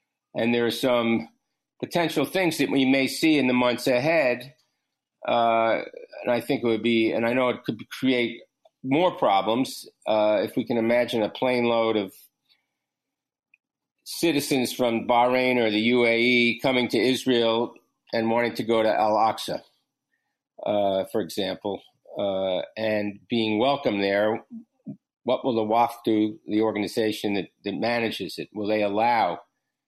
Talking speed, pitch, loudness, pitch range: 155 wpm, 115 Hz, -24 LUFS, 110-125 Hz